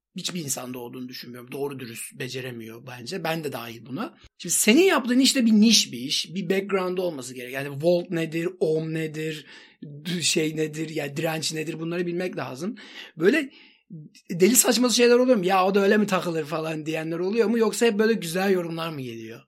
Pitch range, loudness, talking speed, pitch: 145-205 Hz, -23 LUFS, 190 wpm, 170 Hz